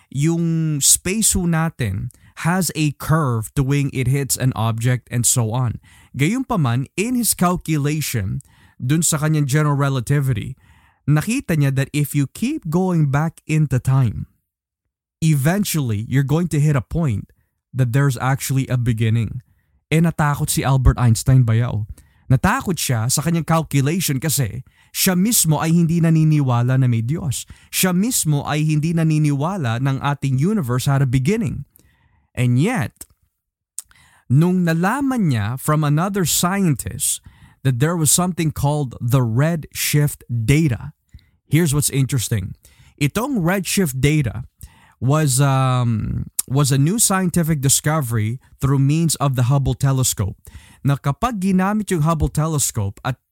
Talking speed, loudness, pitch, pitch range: 135 wpm, -19 LUFS, 140 Hz, 125-160 Hz